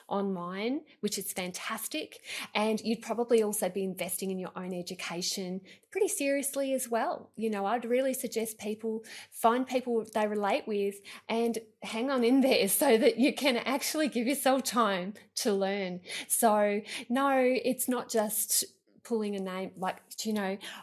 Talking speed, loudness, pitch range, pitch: 160 wpm, -30 LUFS, 200-250 Hz, 220 Hz